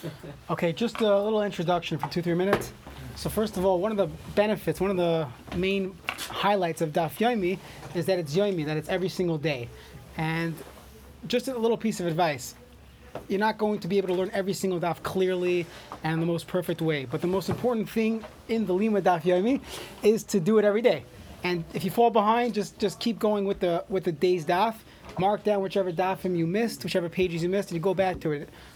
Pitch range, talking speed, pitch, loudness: 170-205 Hz, 220 wpm, 185 Hz, -27 LUFS